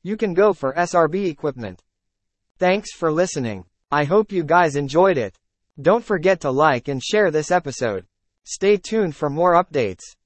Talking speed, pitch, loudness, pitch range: 165 wpm, 165 Hz, -20 LUFS, 135-190 Hz